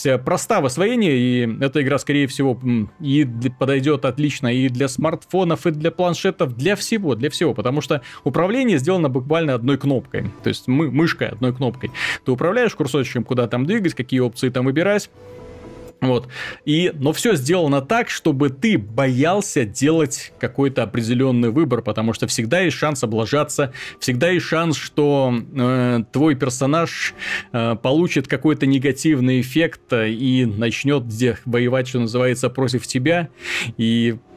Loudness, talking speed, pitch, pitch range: -19 LUFS, 145 wpm, 140 Hz, 125-160 Hz